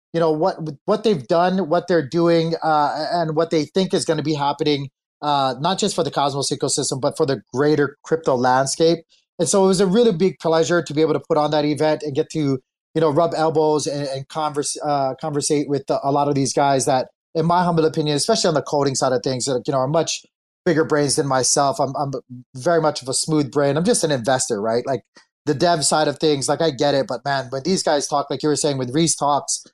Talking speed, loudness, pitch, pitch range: 250 wpm, -20 LUFS, 150 Hz, 140-165 Hz